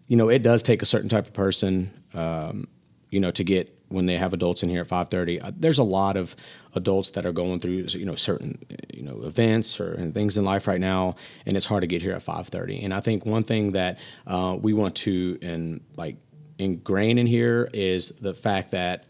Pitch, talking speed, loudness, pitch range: 95 Hz, 225 wpm, -23 LUFS, 90-110 Hz